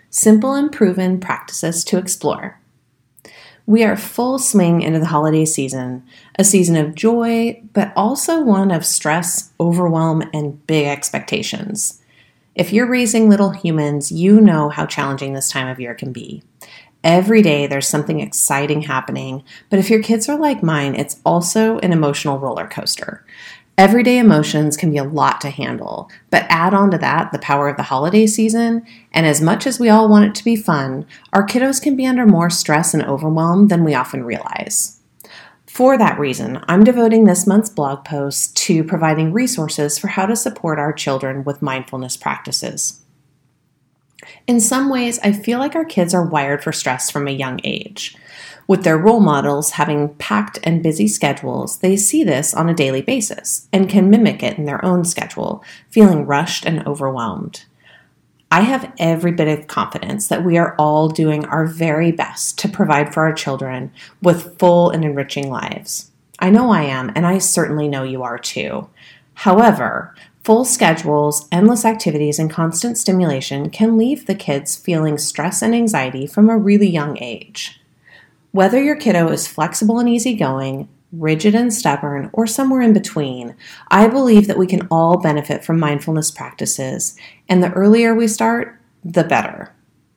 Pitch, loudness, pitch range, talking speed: 170 Hz, -15 LUFS, 150-215 Hz, 170 wpm